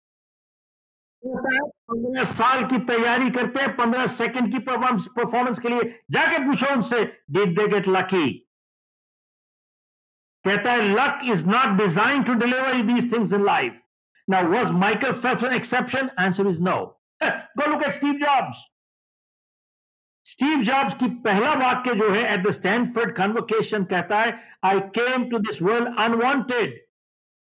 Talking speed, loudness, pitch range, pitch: 140 wpm, -21 LUFS, 210-255 Hz, 240 Hz